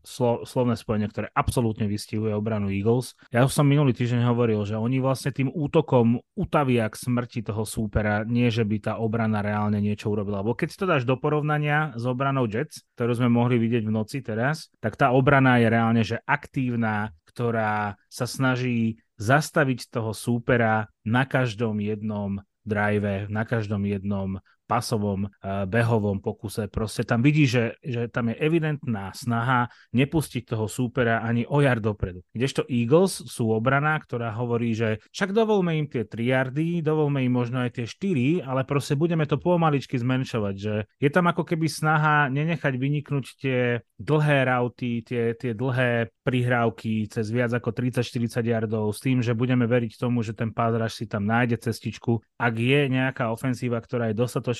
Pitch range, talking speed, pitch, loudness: 110-135 Hz, 165 wpm, 120 Hz, -25 LUFS